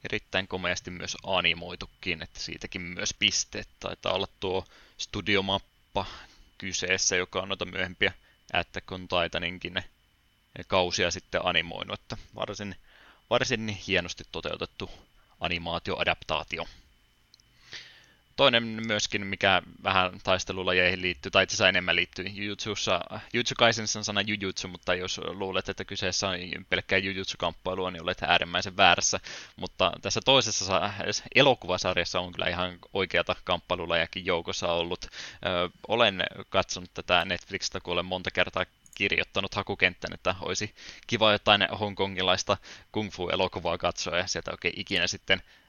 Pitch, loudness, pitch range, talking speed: 95 Hz, -28 LUFS, 90-100 Hz, 120 wpm